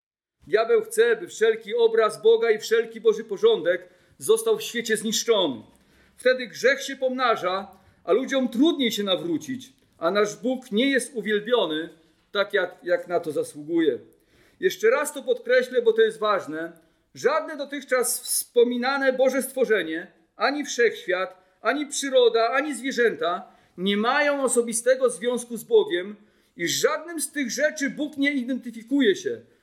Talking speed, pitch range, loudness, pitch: 140 wpm, 215-300 Hz, -24 LUFS, 255 Hz